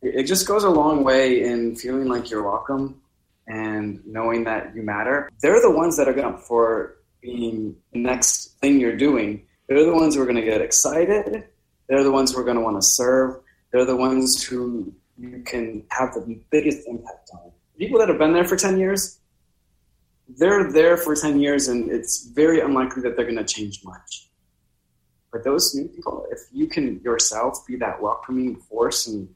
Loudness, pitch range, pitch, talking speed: -20 LUFS, 110-145 Hz, 125 Hz, 190 wpm